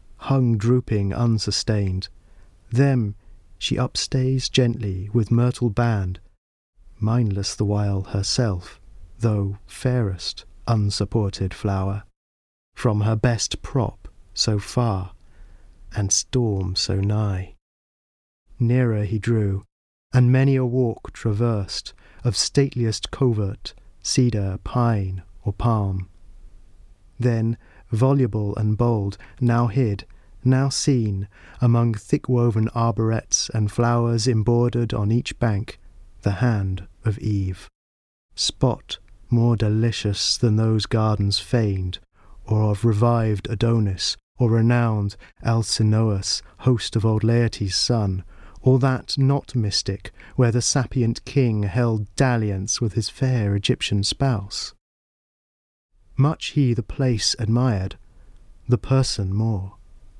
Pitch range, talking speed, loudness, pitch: 95-120 Hz, 105 wpm, -22 LUFS, 110 Hz